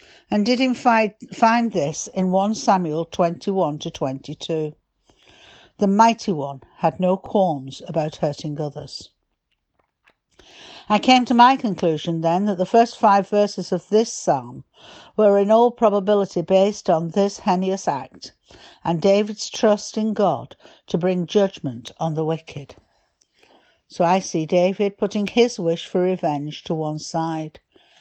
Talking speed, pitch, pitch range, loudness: 140 wpm, 190 Hz, 165-210 Hz, -20 LUFS